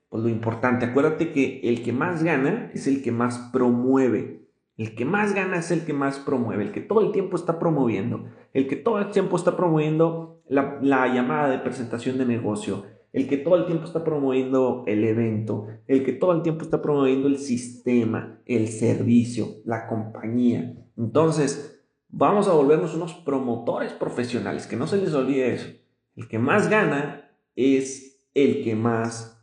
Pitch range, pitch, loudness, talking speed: 115-150 Hz, 130 Hz, -23 LUFS, 175 wpm